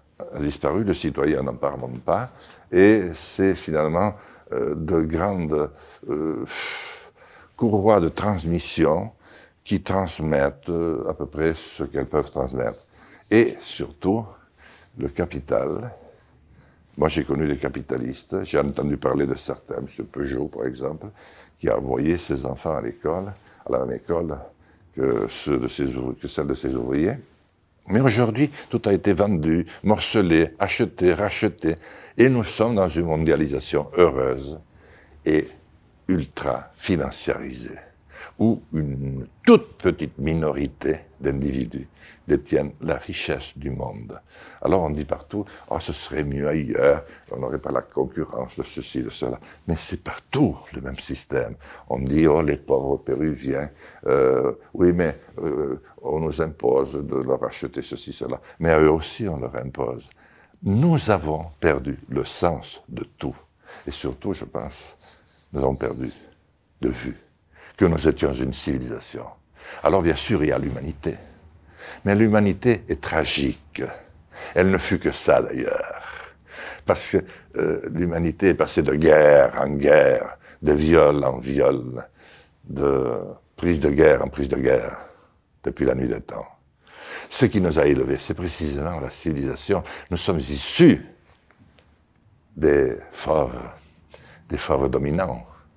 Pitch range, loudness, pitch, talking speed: 70-95 Hz, -23 LUFS, 80 Hz, 145 wpm